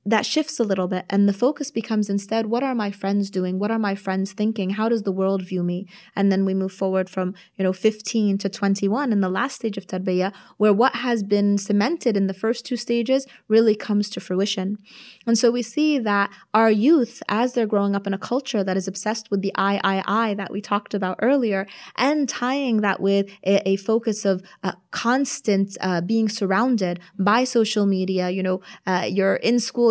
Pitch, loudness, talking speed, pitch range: 205 Hz, -22 LUFS, 215 wpm, 195-230 Hz